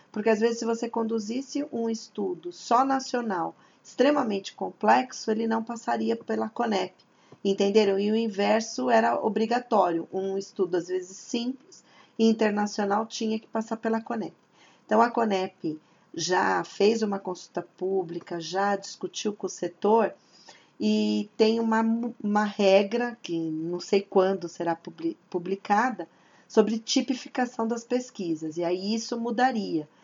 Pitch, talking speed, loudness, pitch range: 215 Hz, 135 wpm, -27 LUFS, 190-230 Hz